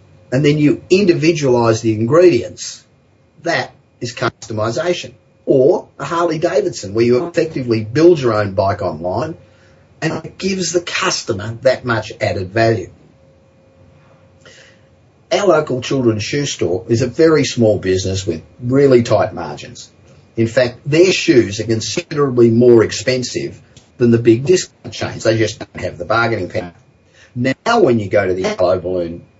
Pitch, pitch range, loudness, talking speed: 120 Hz, 110-145 Hz, -15 LUFS, 145 wpm